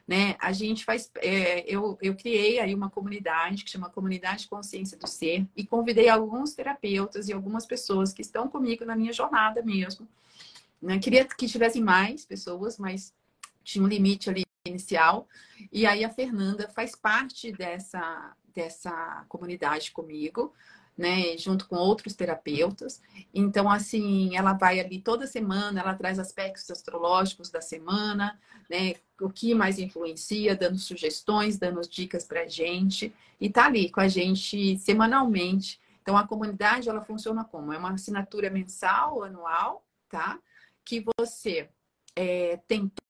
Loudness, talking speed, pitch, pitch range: -27 LUFS, 150 wpm, 195 Hz, 185-220 Hz